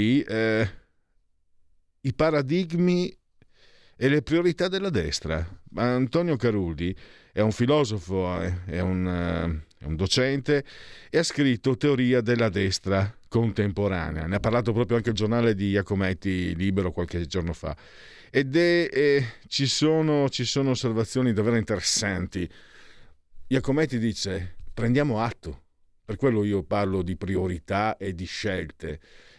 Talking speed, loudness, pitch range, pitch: 125 wpm, -25 LUFS, 90-130 Hz, 105 Hz